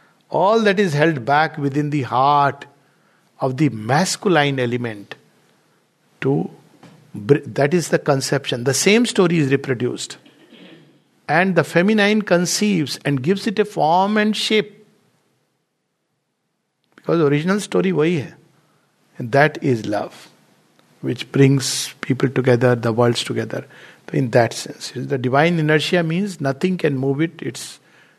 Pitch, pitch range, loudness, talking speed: 150 Hz, 135-185 Hz, -18 LUFS, 130 wpm